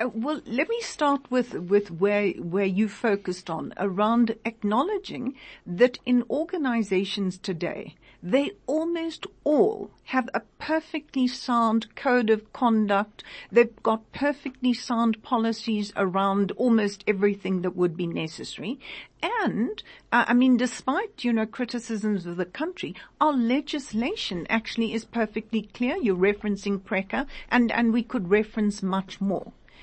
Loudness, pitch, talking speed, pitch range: -26 LUFS, 230 Hz, 135 wpm, 200-255 Hz